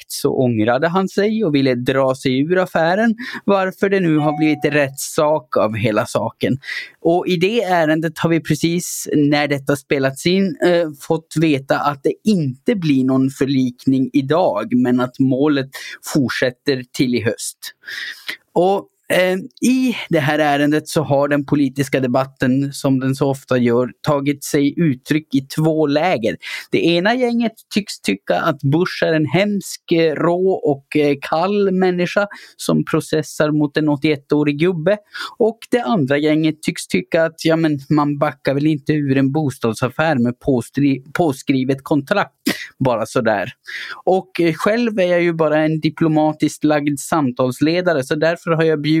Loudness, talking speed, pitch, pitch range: -18 LUFS, 155 wpm, 155 Hz, 140-170 Hz